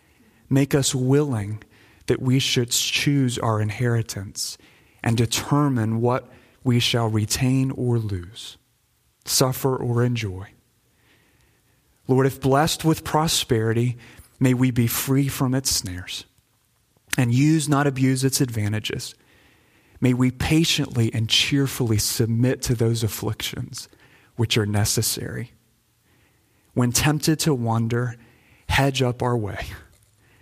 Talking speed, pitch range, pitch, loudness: 115 wpm, 110-130 Hz, 120 Hz, -22 LUFS